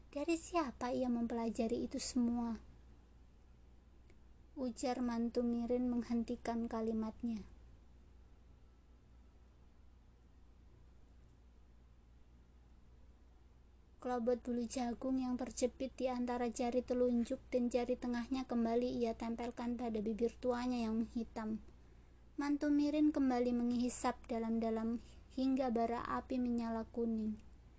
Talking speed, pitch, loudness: 90 wpm, 235 Hz, -38 LUFS